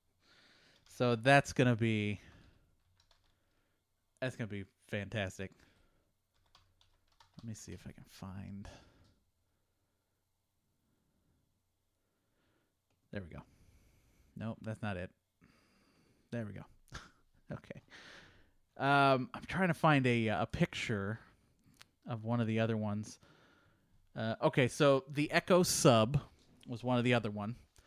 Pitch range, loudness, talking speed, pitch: 95-125 Hz, -33 LUFS, 110 wpm, 110 Hz